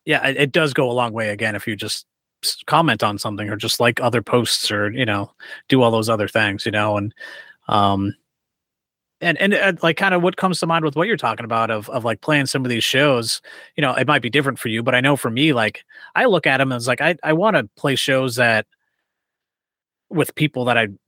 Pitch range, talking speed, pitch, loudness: 110-150 Hz, 240 wpm, 125 Hz, -19 LUFS